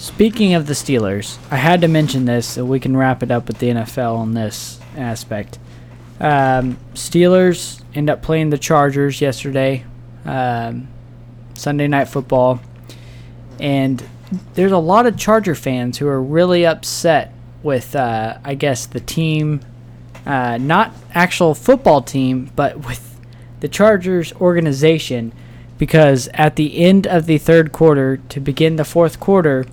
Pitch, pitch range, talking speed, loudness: 135 Hz, 120-155 Hz, 145 wpm, -16 LUFS